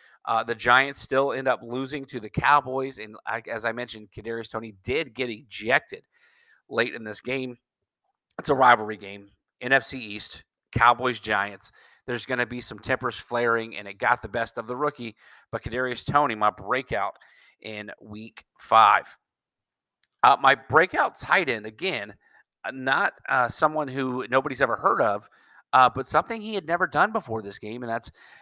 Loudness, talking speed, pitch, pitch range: -24 LUFS, 170 wpm, 120 Hz, 110-135 Hz